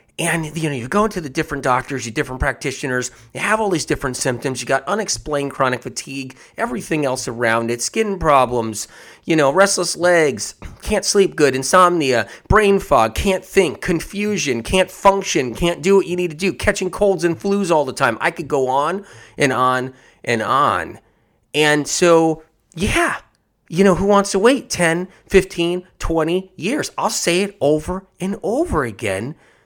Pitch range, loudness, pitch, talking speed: 135-190 Hz, -18 LUFS, 165 Hz, 175 wpm